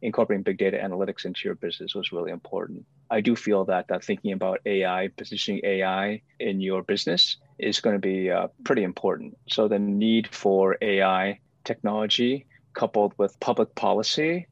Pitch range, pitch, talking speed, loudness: 95-120 Hz, 105 Hz, 165 wpm, -25 LUFS